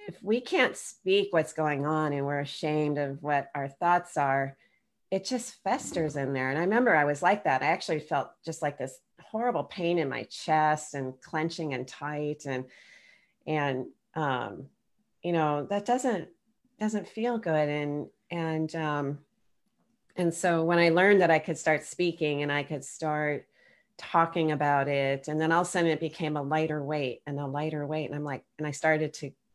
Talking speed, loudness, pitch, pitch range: 190 wpm, -29 LUFS, 155 Hz, 145-175 Hz